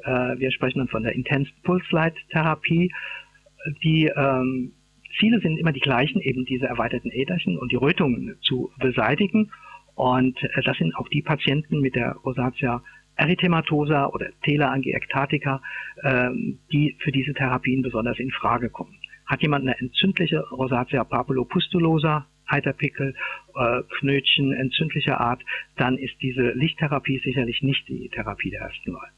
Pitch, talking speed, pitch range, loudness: 140 Hz, 140 wpm, 130-155 Hz, -23 LUFS